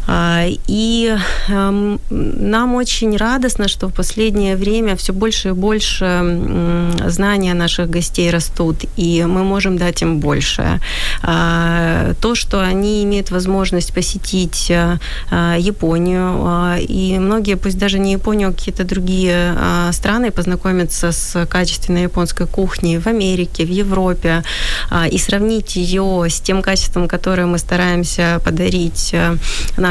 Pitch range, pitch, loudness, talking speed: 175-200 Hz, 185 Hz, -16 LUFS, 120 wpm